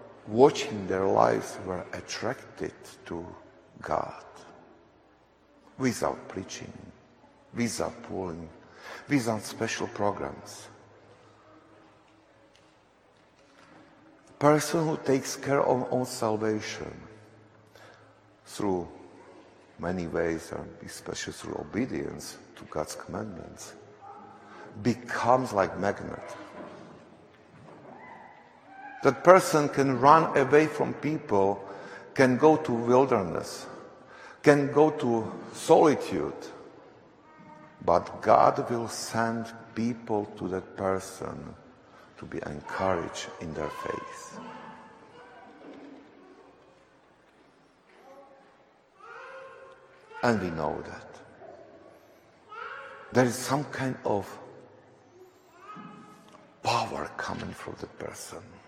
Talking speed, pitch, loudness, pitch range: 80 wpm, 125 Hz, -28 LUFS, 110-155 Hz